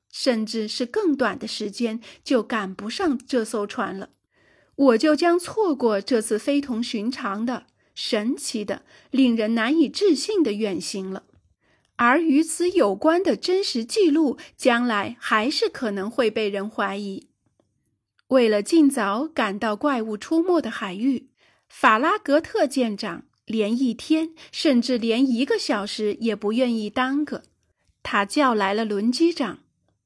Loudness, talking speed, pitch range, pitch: -22 LUFS, 210 characters per minute, 220-295 Hz, 245 Hz